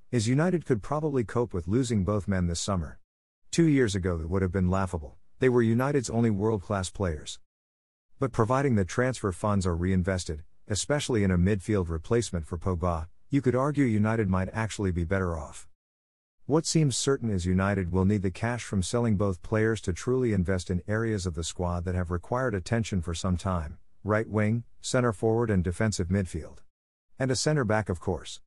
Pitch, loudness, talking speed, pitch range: 100 Hz, -28 LUFS, 190 wpm, 90-115 Hz